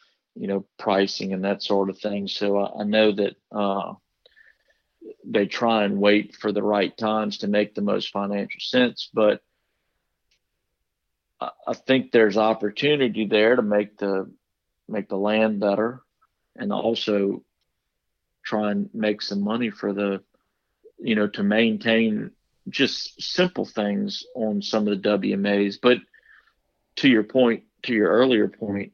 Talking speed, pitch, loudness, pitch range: 145 wpm, 105 Hz, -23 LUFS, 100-110 Hz